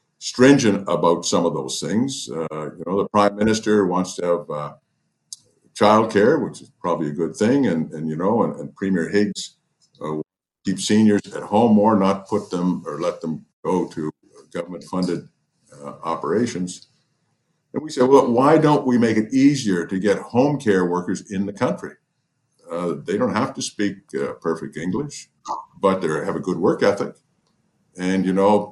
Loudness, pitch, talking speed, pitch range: -20 LUFS, 100 Hz, 180 wpm, 90-110 Hz